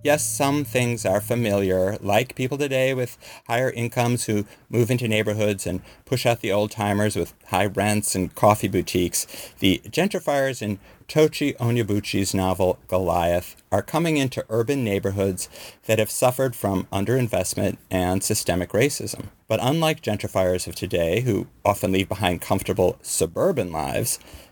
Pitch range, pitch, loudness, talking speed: 95-125 Hz, 105 Hz, -23 LUFS, 145 wpm